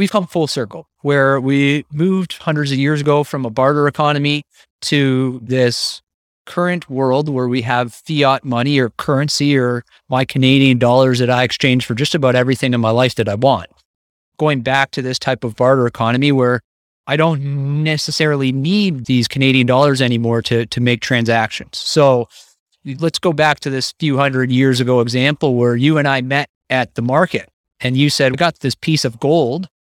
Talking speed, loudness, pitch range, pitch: 185 wpm, -15 LUFS, 125-145 Hz, 135 Hz